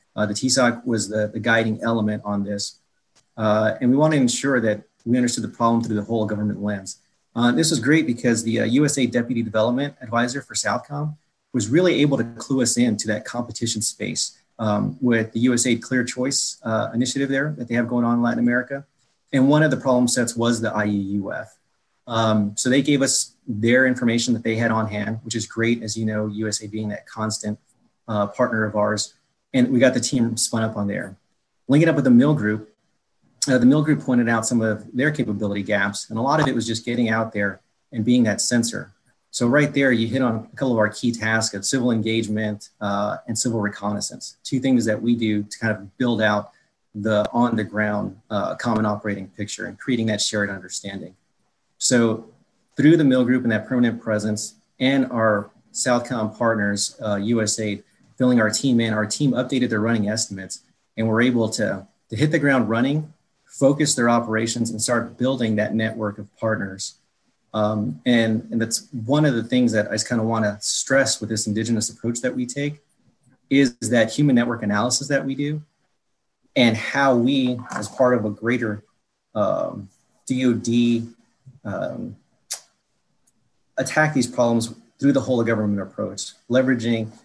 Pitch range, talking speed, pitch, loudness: 110-125 Hz, 195 wpm, 115 Hz, -21 LUFS